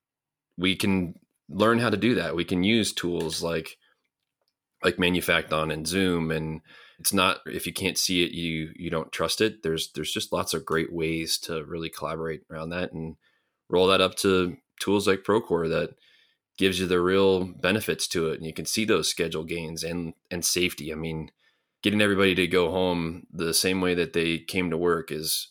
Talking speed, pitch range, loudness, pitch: 195 wpm, 80-95 Hz, -26 LUFS, 85 Hz